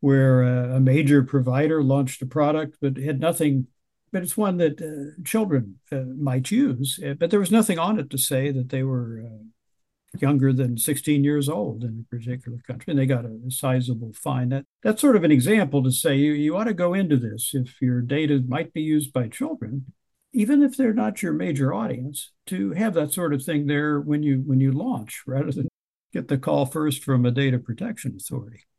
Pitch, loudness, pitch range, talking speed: 140 Hz, -23 LUFS, 130-155 Hz, 210 wpm